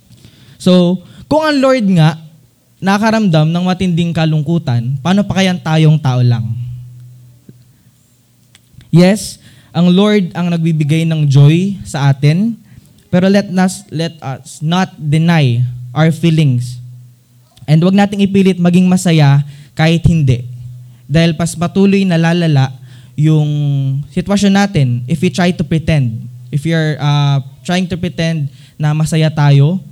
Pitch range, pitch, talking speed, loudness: 135-180 Hz, 155 Hz, 125 wpm, -12 LUFS